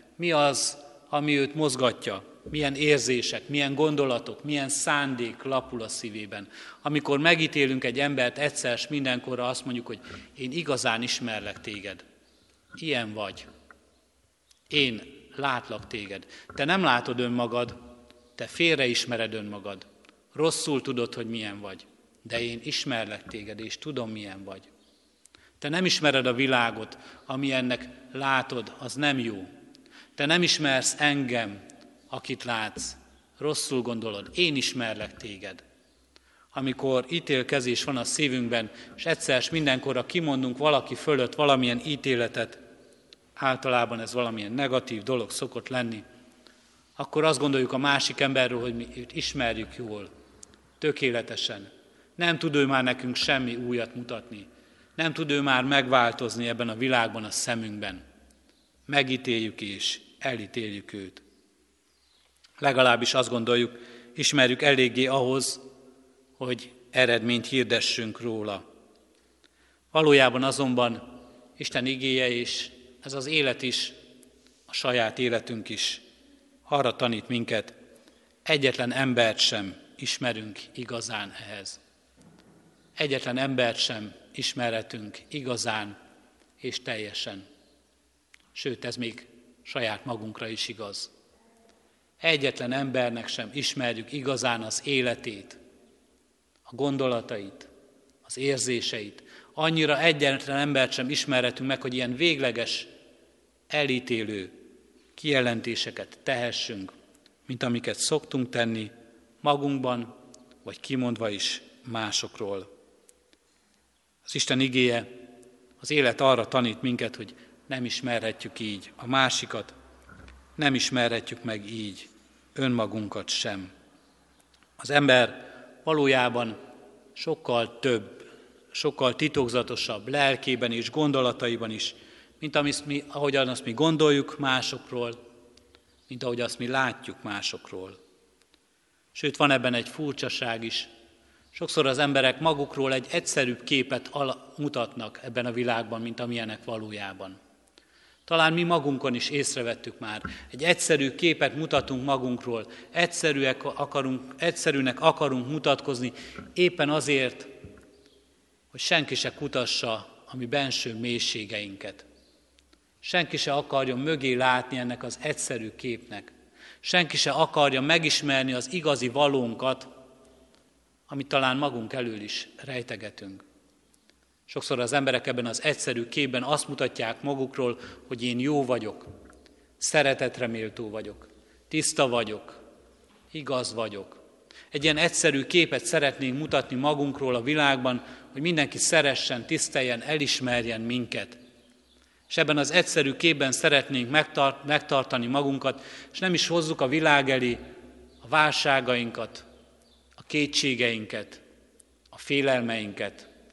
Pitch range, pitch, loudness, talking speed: 120-140 Hz, 125 Hz, -26 LUFS, 110 wpm